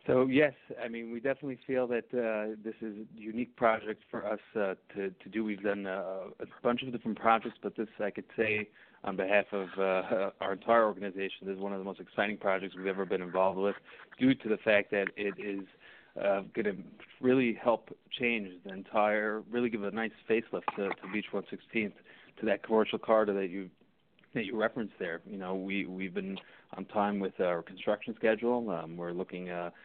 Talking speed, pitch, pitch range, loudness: 205 wpm, 105 Hz, 95-115 Hz, -33 LUFS